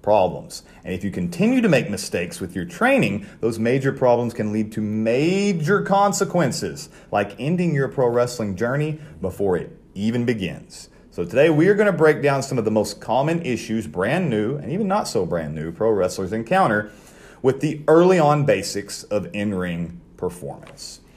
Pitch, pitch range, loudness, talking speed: 120 Hz, 105-160 Hz, -21 LUFS, 180 wpm